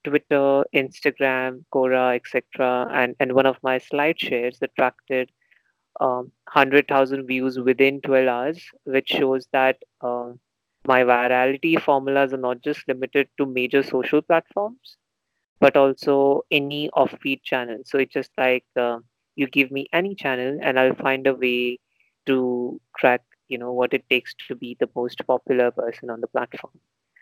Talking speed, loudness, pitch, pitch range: 150 wpm, -22 LUFS, 130 Hz, 125-140 Hz